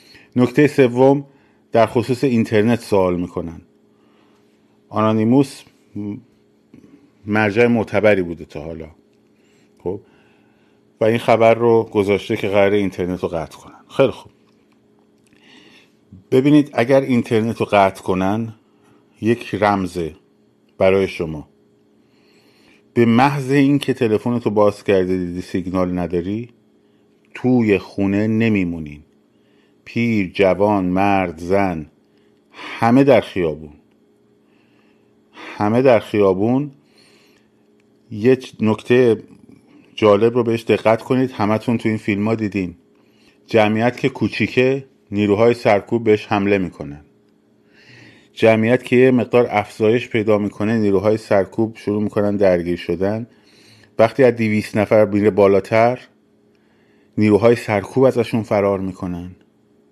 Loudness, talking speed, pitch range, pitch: -17 LUFS, 105 wpm, 95-115 Hz, 105 Hz